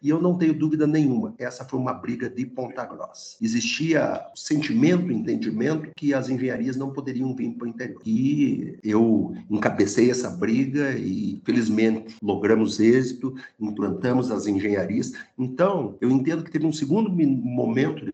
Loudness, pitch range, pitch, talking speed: -24 LUFS, 120-160 Hz, 130 Hz, 150 wpm